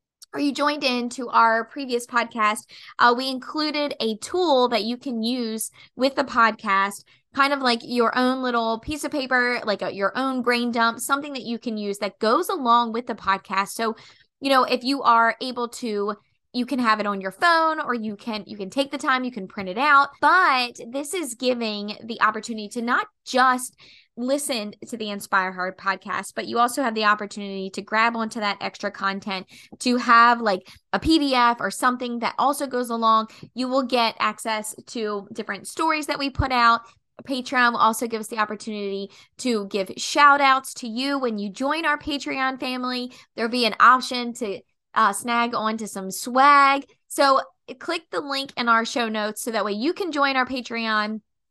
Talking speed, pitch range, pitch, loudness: 195 wpm, 215-265 Hz, 240 Hz, -22 LUFS